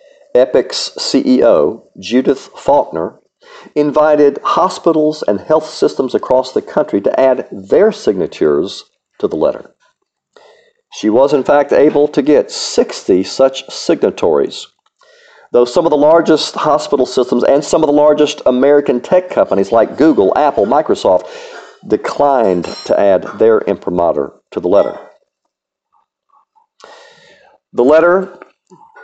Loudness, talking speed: -12 LUFS, 120 wpm